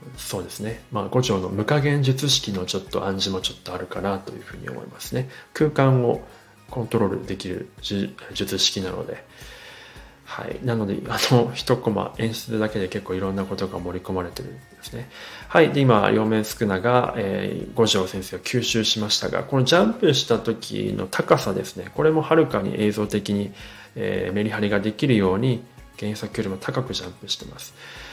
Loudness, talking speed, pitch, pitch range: -23 LUFS, 365 characters per minute, 110 Hz, 100-125 Hz